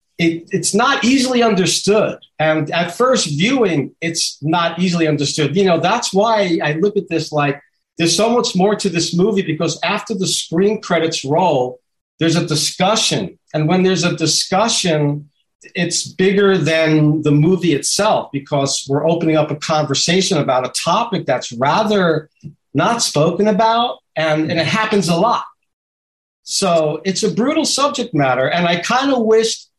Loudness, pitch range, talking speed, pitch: -16 LUFS, 155-205 Hz, 160 wpm, 170 Hz